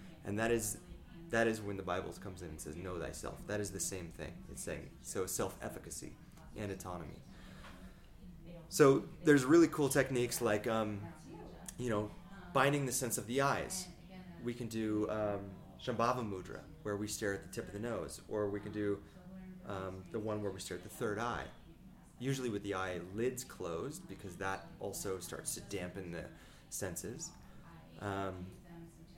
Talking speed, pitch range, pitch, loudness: 175 wpm, 95-125 Hz, 105 Hz, -38 LUFS